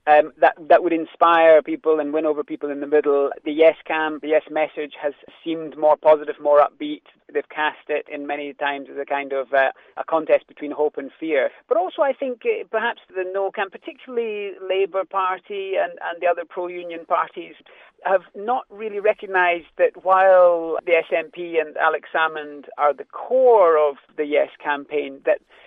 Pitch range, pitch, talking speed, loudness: 150-190 Hz, 160 Hz, 185 wpm, -21 LUFS